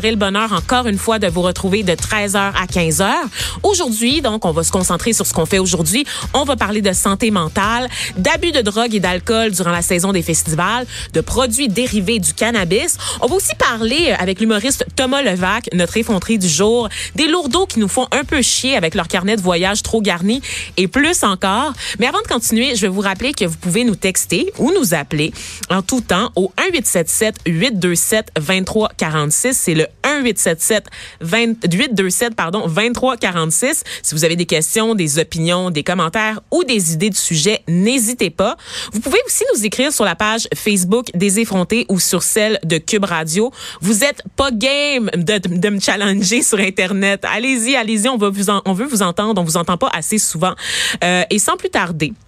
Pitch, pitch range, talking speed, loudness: 210 Hz, 180-240 Hz, 190 wpm, -15 LUFS